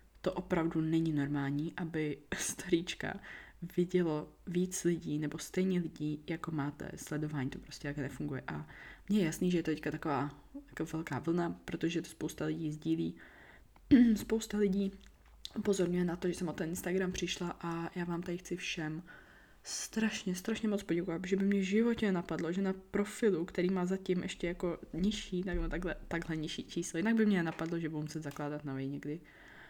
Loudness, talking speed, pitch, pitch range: -35 LUFS, 175 wpm, 170 Hz, 155-185 Hz